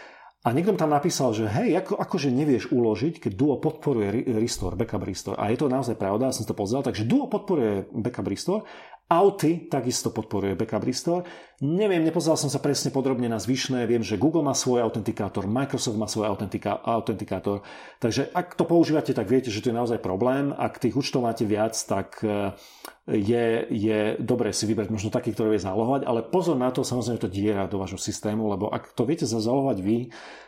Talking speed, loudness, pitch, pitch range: 195 wpm, -25 LUFS, 120 Hz, 110-140 Hz